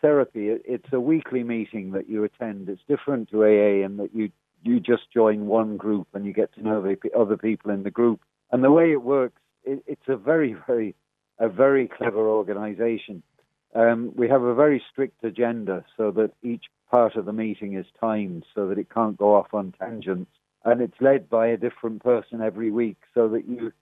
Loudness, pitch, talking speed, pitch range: -24 LUFS, 115 Hz, 205 wpm, 105-125 Hz